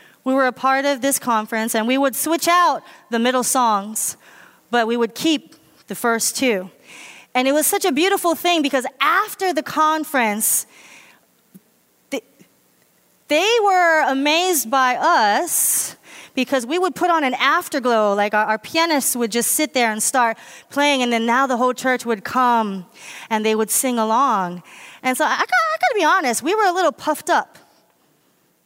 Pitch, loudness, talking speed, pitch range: 260 Hz, -18 LUFS, 180 wpm, 230-315 Hz